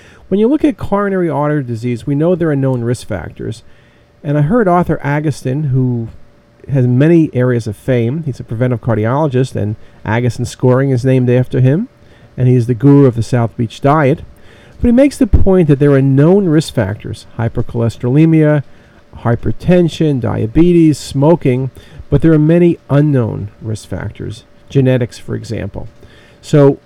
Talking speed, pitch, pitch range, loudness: 160 wpm, 130 Hz, 115-150 Hz, -13 LUFS